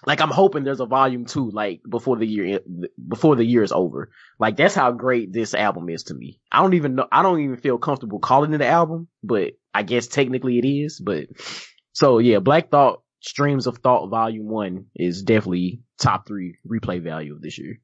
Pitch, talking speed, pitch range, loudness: 125 Hz, 210 wpm, 105-145 Hz, -20 LUFS